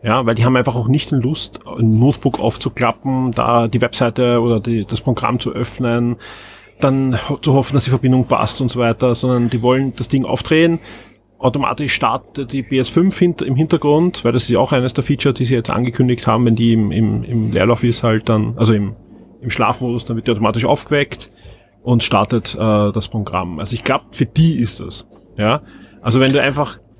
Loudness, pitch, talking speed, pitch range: -16 LUFS, 120 Hz, 200 wpm, 115-135 Hz